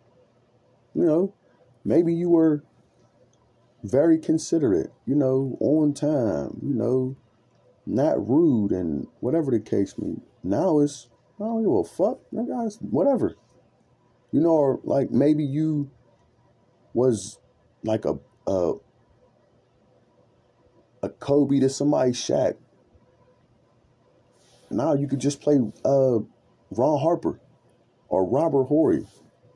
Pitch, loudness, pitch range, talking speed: 140 Hz, -24 LUFS, 125-155 Hz, 115 wpm